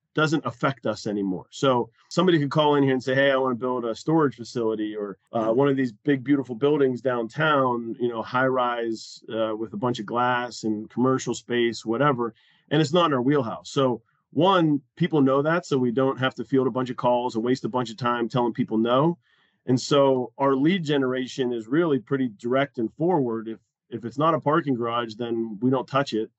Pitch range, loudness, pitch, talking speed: 115-140 Hz, -24 LUFS, 130 Hz, 220 wpm